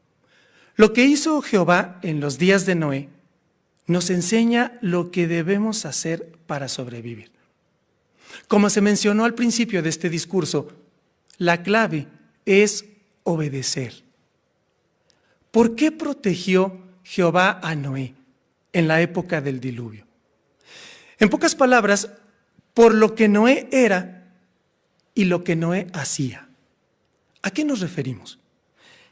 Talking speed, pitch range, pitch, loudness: 115 wpm, 160-215 Hz, 185 Hz, -20 LUFS